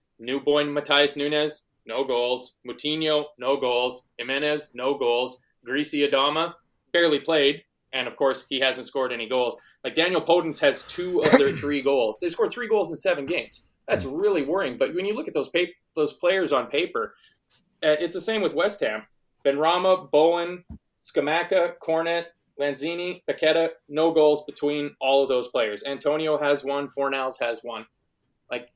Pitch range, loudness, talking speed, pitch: 135-170 Hz, -24 LUFS, 165 wpm, 145 Hz